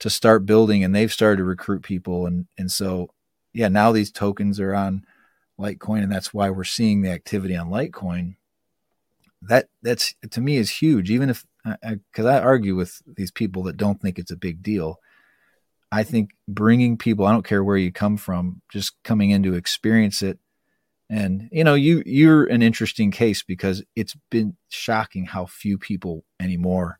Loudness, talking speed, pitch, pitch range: -21 LUFS, 180 wpm, 100 Hz, 95-110 Hz